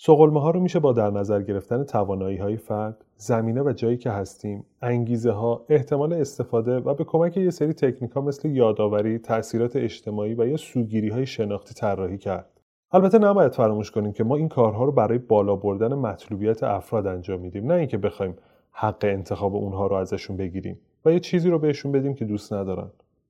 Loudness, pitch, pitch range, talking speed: -23 LUFS, 115 Hz, 100-140 Hz, 185 wpm